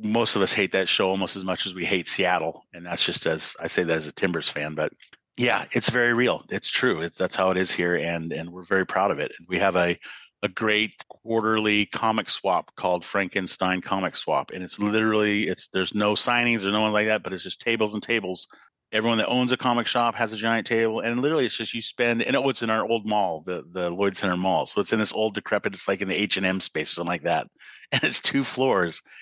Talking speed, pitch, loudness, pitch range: 255 wpm, 105 Hz, -24 LUFS, 95-115 Hz